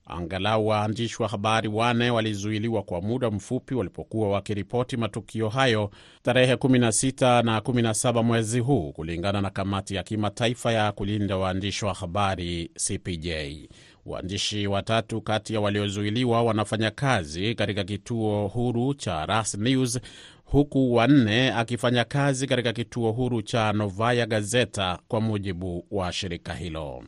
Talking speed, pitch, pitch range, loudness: 130 wpm, 110 Hz, 100-120 Hz, -25 LUFS